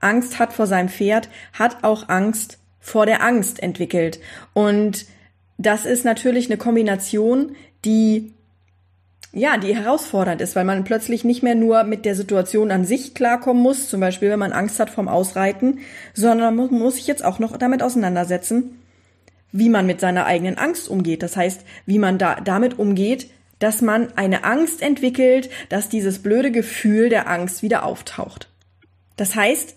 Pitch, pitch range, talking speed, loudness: 215 Hz, 185-240 Hz, 165 wpm, -19 LUFS